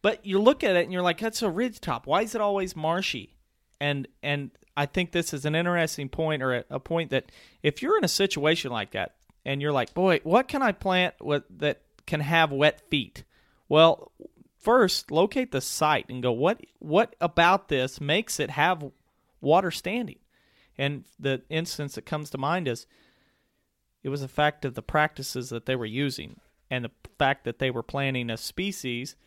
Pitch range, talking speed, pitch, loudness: 130-175 Hz, 195 wpm, 150 Hz, -26 LUFS